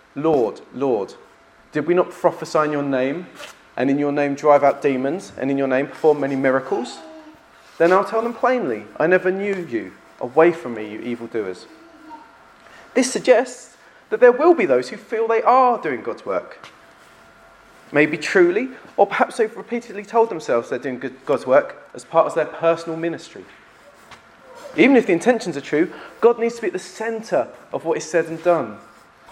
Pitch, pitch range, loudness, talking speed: 175 Hz, 145-235 Hz, -20 LUFS, 180 wpm